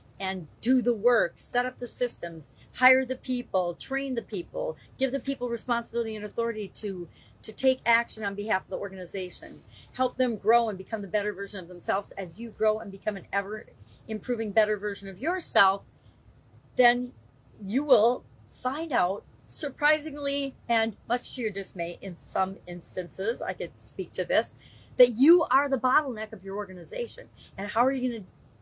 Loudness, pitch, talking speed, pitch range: -28 LUFS, 225 Hz, 175 wpm, 195-255 Hz